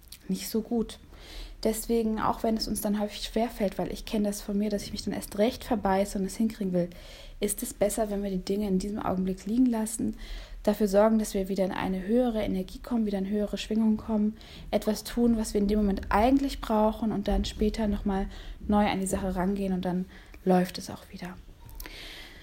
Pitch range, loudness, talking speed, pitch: 195-220 Hz, -29 LUFS, 210 wpm, 210 Hz